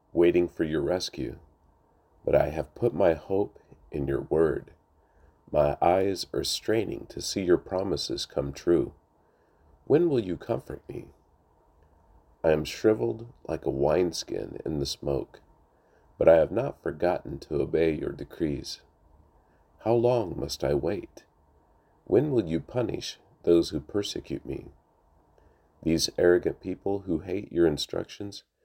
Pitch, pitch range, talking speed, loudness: 85 Hz, 75-100 Hz, 140 wpm, -27 LUFS